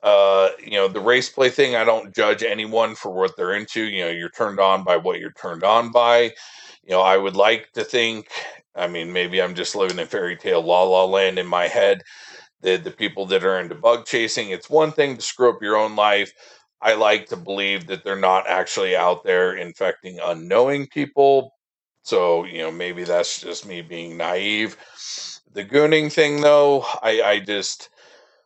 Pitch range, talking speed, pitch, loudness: 95-140 Hz, 200 wpm, 105 Hz, -20 LUFS